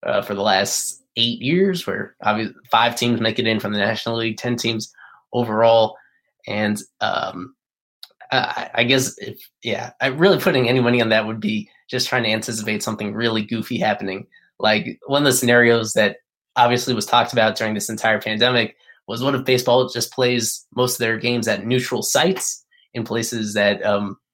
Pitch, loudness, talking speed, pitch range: 120 Hz, -19 LUFS, 185 wpm, 110-125 Hz